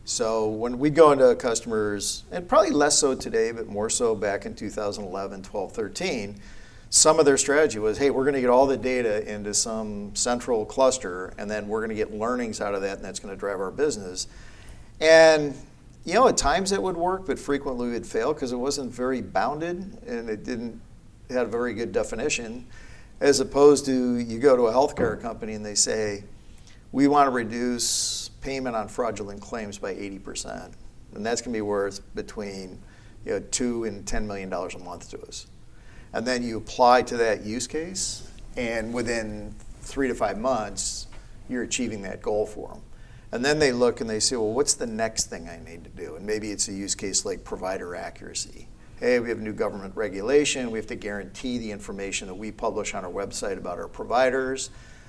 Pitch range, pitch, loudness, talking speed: 105-135 Hz, 115 Hz, -25 LUFS, 200 wpm